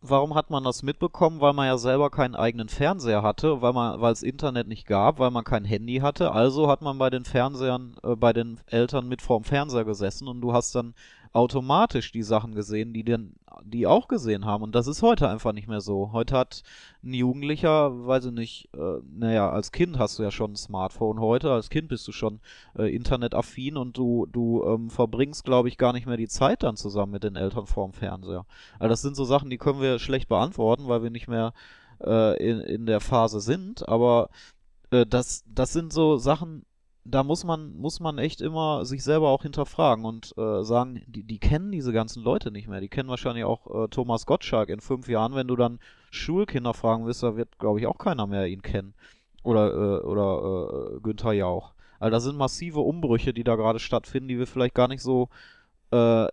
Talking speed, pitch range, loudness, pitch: 215 wpm, 110-135 Hz, -26 LUFS, 120 Hz